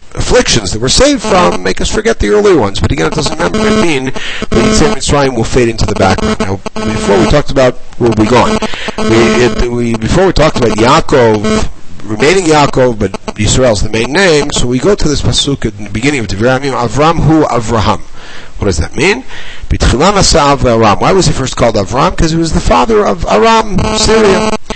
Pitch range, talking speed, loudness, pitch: 115-175 Hz, 200 wpm, -10 LUFS, 130 Hz